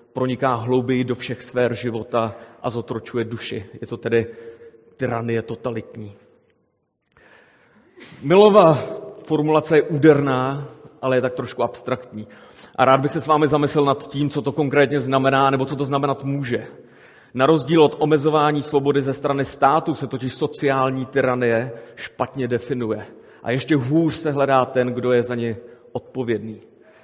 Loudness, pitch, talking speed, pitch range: -20 LUFS, 130 Hz, 145 wpm, 120-145 Hz